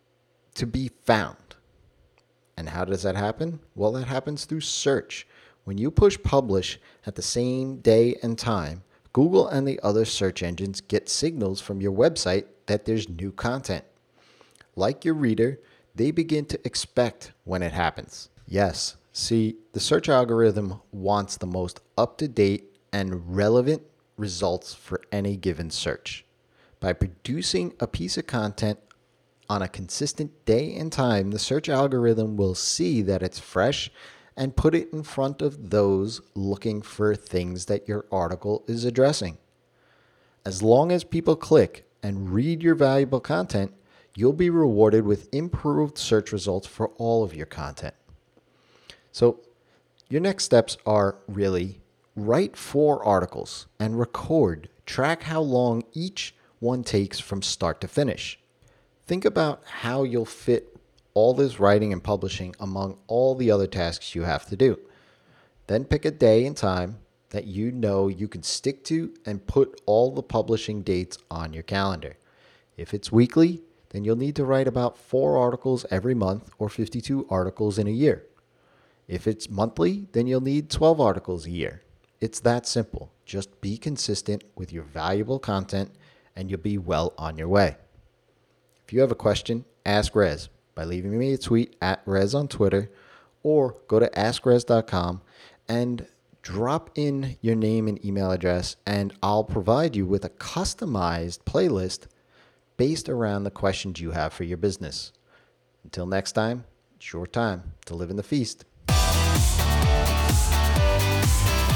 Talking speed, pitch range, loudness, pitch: 155 wpm, 95-130 Hz, -25 LUFS, 105 Hz